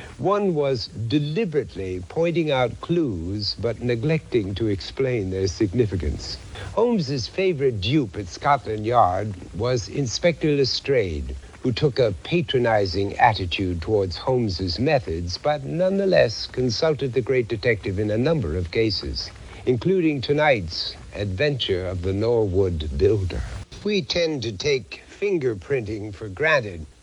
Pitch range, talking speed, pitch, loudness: 95-145 Hz, 120 wpm, 115 Hz, -23 LUFS